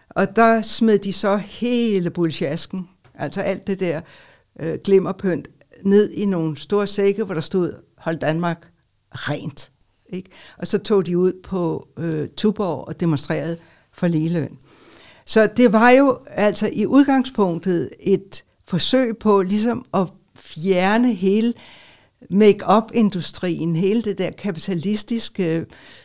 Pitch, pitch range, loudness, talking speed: 190 Hz, 165-210 Hz, -20 LUFS, 130 wpm